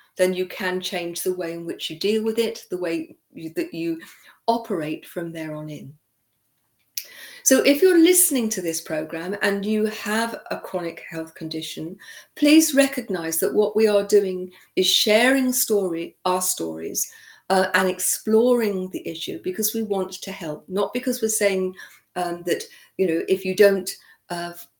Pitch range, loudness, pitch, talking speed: 170-220 Hz, -22 LUFS, 185 Hz, 170 wpm